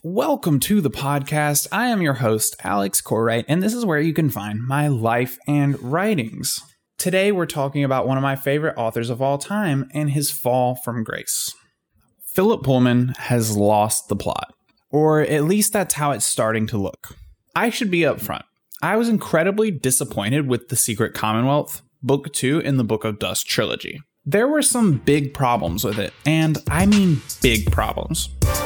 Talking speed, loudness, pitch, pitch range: 180 wpm, -20 LUFS, 140 Hz, 115-165 Hz